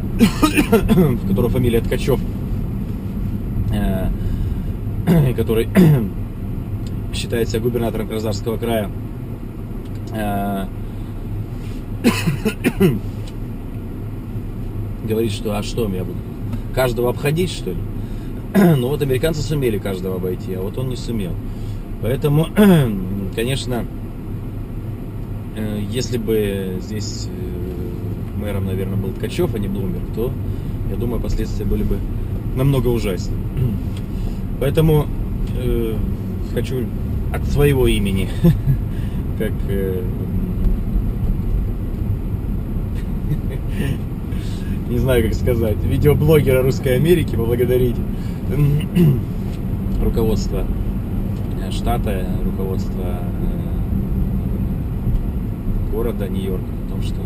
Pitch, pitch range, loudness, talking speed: 105 Hz, 100-115 Hz, -20 LUFS, 80 wpm